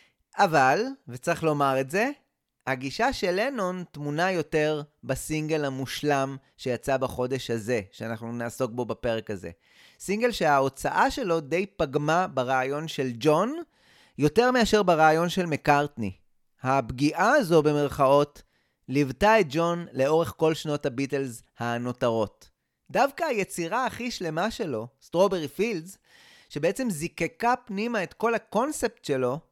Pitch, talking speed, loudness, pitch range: 150 Hz, 120 wpm, -26 LUFS, 130-185 Hz